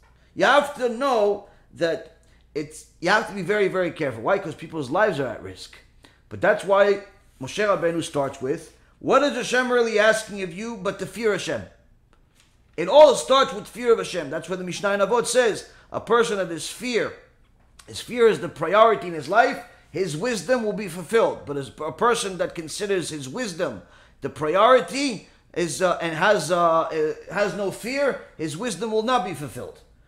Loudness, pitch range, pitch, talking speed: -22 LUFS, 165-235 Hz, 200 Hz, 190 wpm